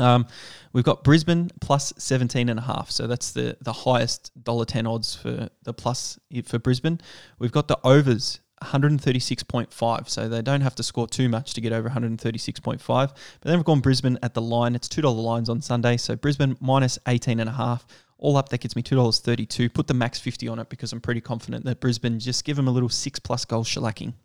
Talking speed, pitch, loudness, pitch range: 250 wpm, 125 Hz, -24 LUFS, 115-135 Hz